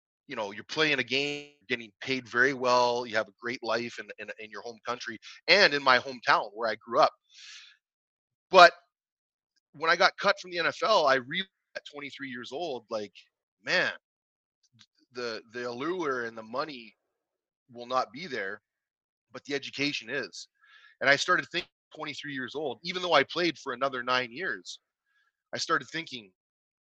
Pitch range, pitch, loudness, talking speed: 120-160 Hz, 135 Hz, -28 LUFS, 170 wpm